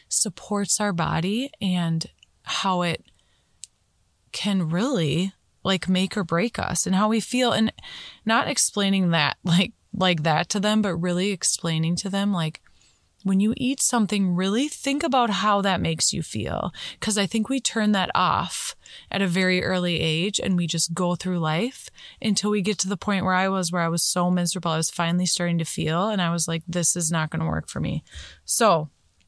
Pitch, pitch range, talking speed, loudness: 185 Hz, 170-210 Hz, 195 wpm, -23 LUFS